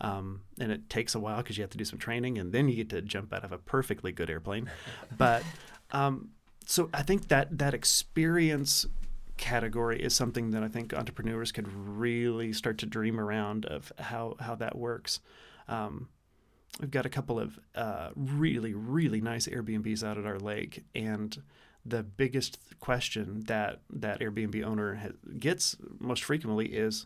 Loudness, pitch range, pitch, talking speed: -32 LUFS, 105-125 Hz, 115 Hz, 175 wpm